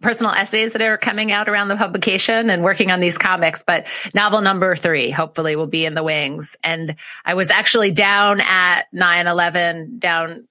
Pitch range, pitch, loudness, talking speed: 165-210 Hz, 185 Hz, -16 LUFS, 190 wpm